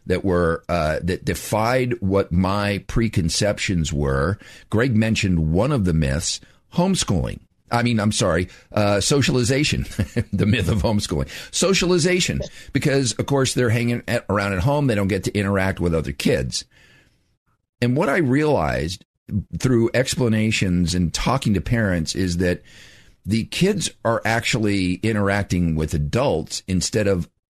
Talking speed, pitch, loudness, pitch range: 140 wpm, 105 Hz, -21 LUFS, 90-120 Hz